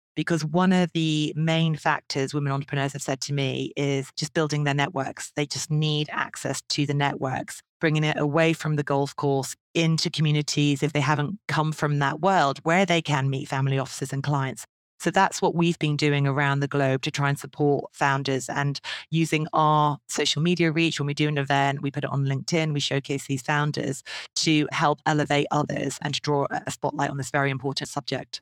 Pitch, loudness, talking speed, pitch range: 145 Hz, -25 LUFS, 205 wpm, 140-155 Hz